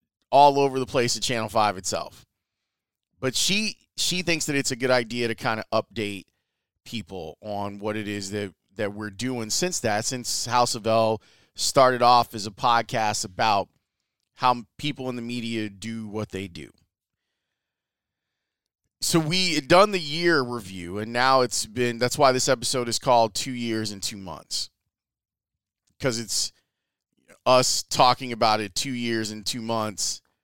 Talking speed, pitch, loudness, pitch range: 165 wpm, 115 Hz, -24 LUFS, 105-130 Hz